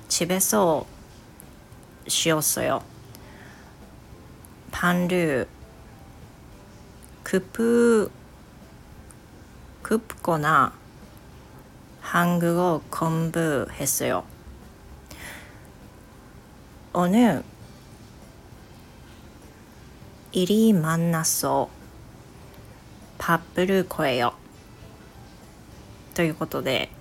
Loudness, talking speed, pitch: -23 LUFS, 125 characters per minute, 160 Hz